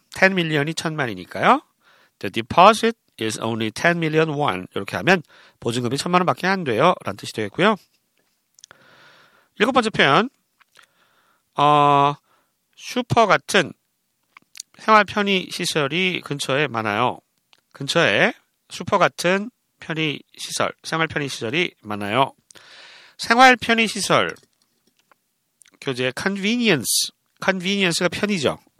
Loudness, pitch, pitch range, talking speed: -20 LUFS, 170 Hz, 135-200 Hz, 290 characters per minute